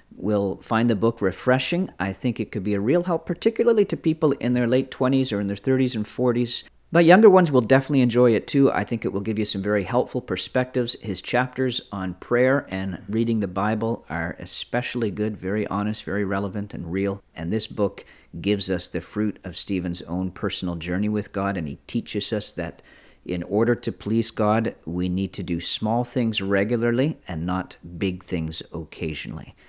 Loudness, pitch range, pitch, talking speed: -23 LUFS, 95-125 Hz, 105 Hz, 195 wpm